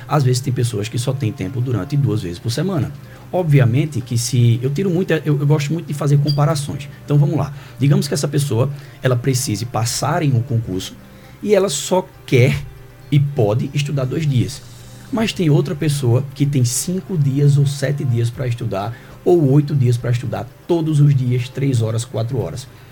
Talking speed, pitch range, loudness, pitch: 190 wpm, 125-145 Hz, -18 LUFS, 135 Hz